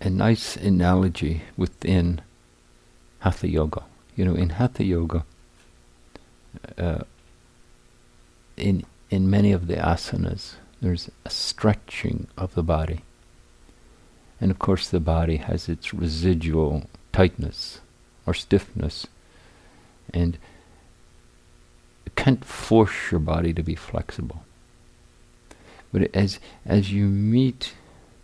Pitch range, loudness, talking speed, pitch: 80-100 Hz, -24 LUFS, 105 wpm, 90 Hz